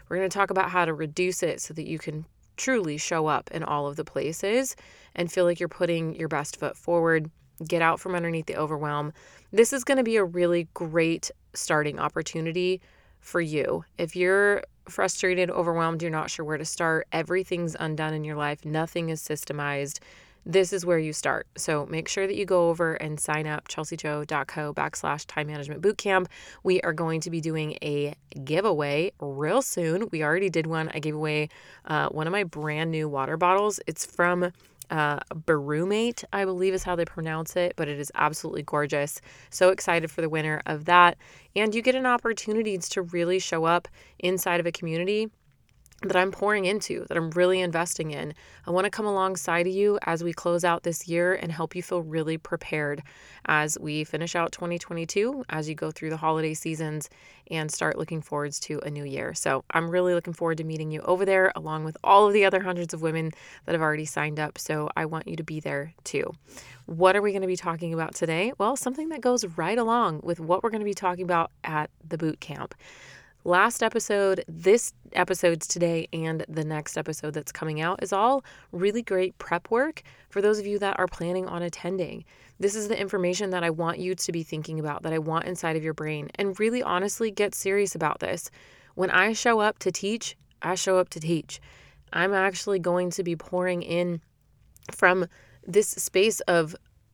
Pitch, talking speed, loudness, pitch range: 170 Hz, 205 wpm, -26 LUFS, 155-185 Hz